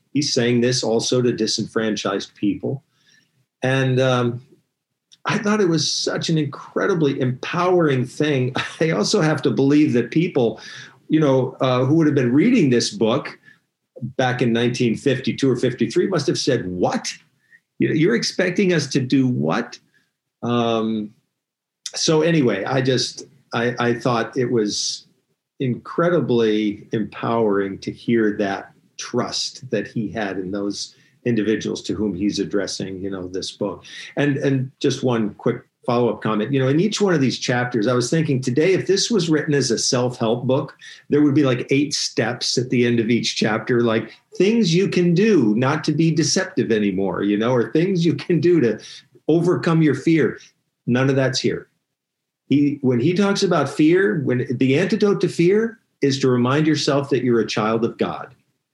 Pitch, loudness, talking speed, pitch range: 130 Hz, -20 LUFS, 170 wpm, 115-155 Hz